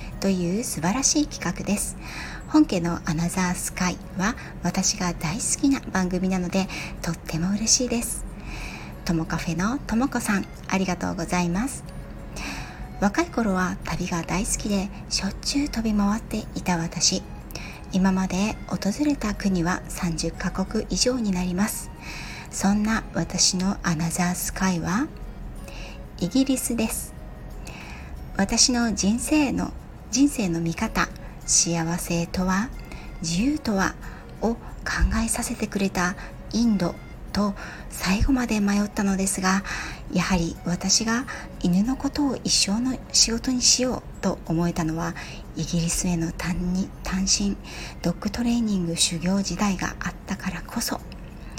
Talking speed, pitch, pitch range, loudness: 255 characters per minute, 190 Hz, 175-225 Hz, -24 LUFS